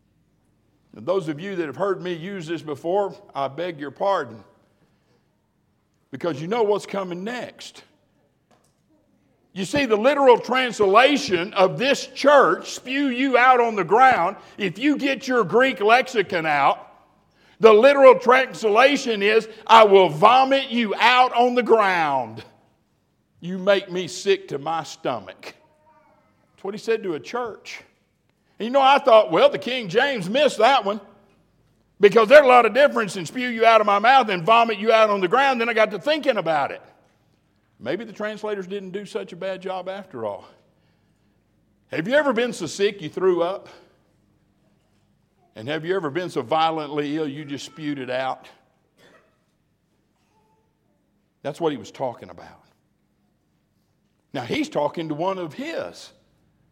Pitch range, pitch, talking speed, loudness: 180-245 Hz, 205 Hz, 160 wpm, -19 LUFS